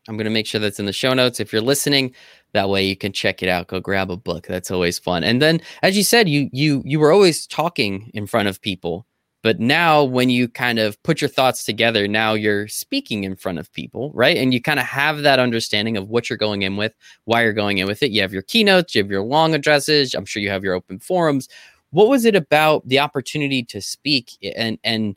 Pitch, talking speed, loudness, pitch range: 115 Hz, 250 wpm, -18 LUFS, 100-145 Hz